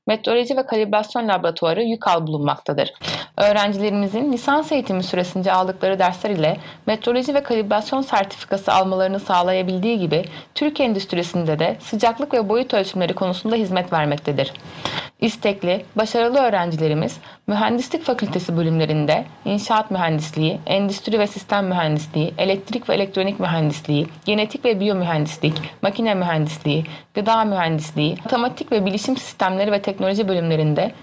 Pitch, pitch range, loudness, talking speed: 195 Hz, 165-220 Hz, -20 LUFS, 115 wpm